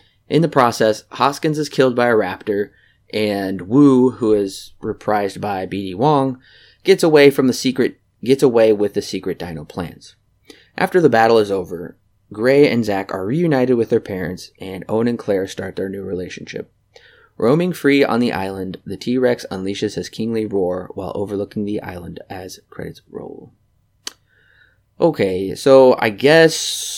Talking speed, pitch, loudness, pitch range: 160 wpm, 110 Hz, -17 LUFS, 100-135 Hz